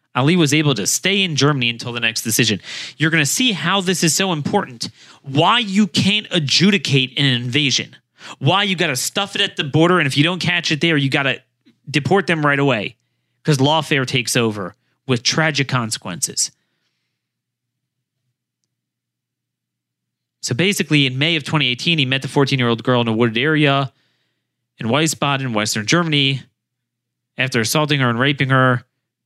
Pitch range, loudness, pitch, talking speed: 125-165 Hz, -17 LUFS, 140 Hz, 165 wpm